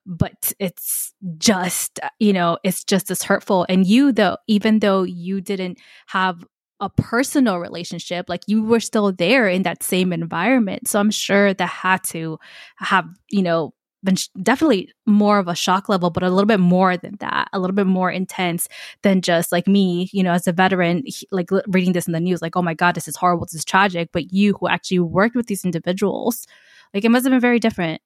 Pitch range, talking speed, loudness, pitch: 175-210 Hz, 215 wpm, -19 LUFS, 185 Hz